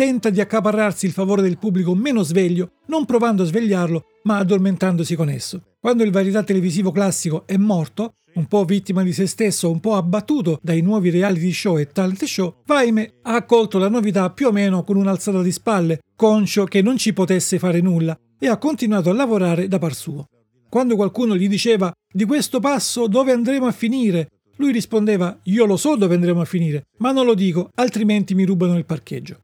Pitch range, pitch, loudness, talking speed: 180-225 Hz, 195 Hz, -18 LUFS, 195 wpm